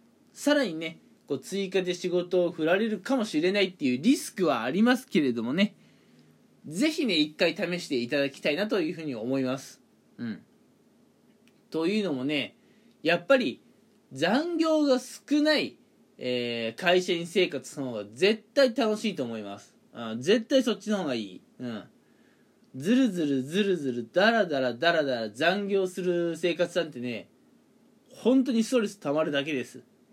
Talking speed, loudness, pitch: 310 characters per minute, -27 LUFS, 185 Hz